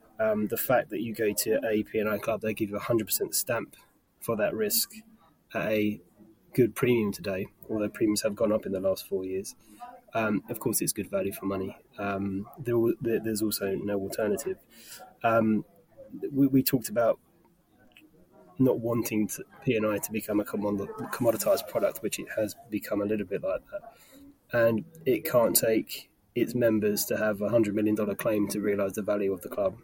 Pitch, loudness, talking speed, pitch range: 110 Hz, -28 LUFS, 190 wpm, 105-135 Hz